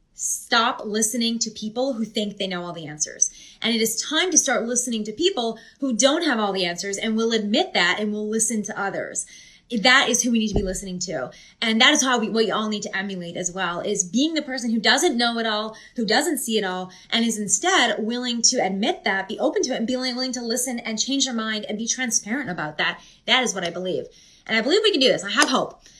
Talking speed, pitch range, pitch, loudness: 255 wpm, 205-250 Hz, 225 Hz, -22 LUFS